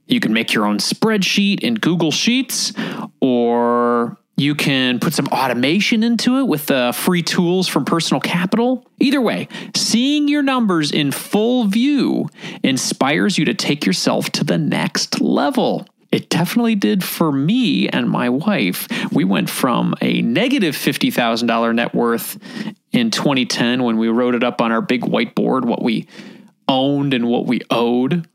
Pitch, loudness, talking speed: 185 Hz, -17 LUFS, 160 wpm